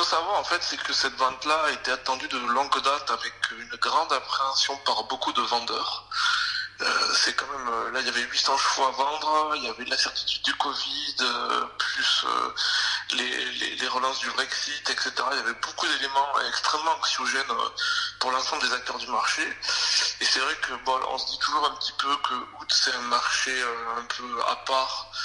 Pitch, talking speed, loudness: 155 Hz, 195 wpm, -25 LUFS